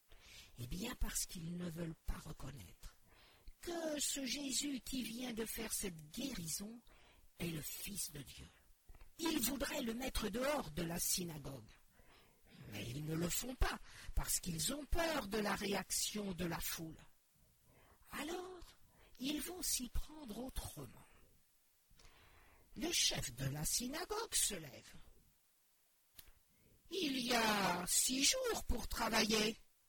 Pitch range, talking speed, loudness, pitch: 170-280 Hz, 130 wpm, -40 LUFS, 225 Hz